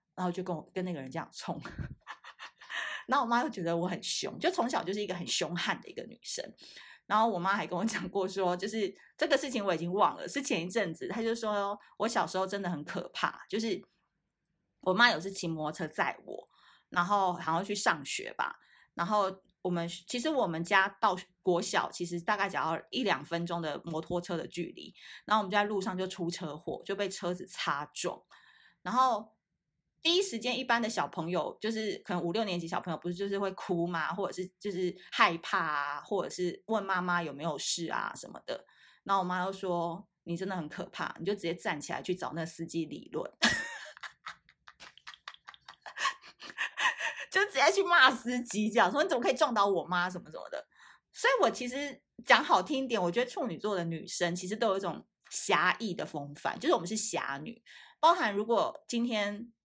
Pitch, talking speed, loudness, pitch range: 190 Hz, 290 characters per minute, -32 LUFS, 175-220 Hz